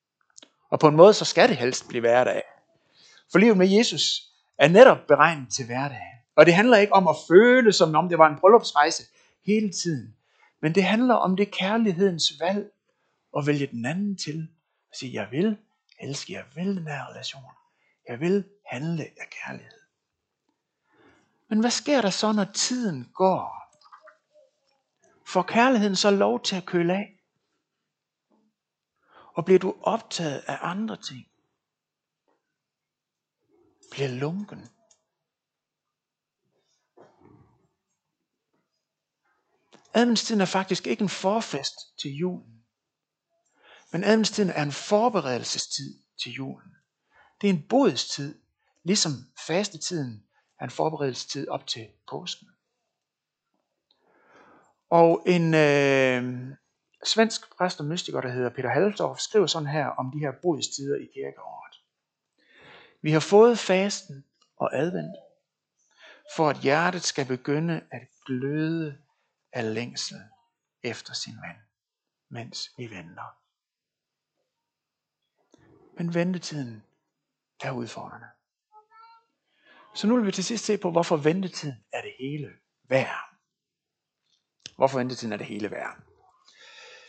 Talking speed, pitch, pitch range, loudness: 125 wpm, 175 Hz, 145-210 Hz, -23 LUFS